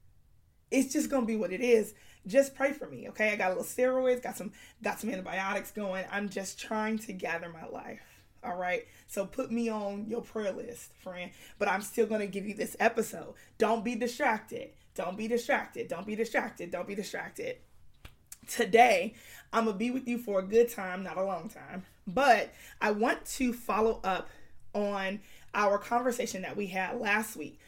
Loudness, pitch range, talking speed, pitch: -31 LUFS, 195-240 Hz, 190 wpm, 220 Hz